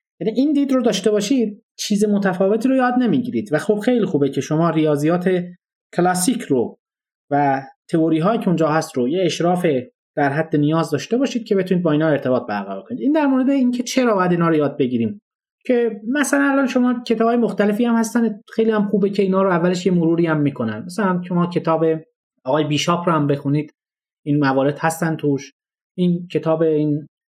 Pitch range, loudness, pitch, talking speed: 155-230 Hz, -19 LUFS, 180 Hz, 185 wpm